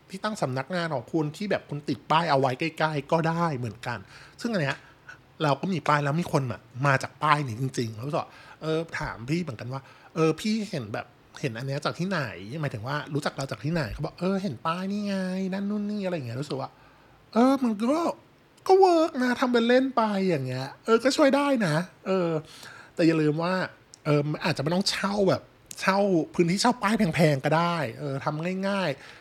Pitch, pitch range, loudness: 160 Hz, 140-190 Hz, -26 LUFS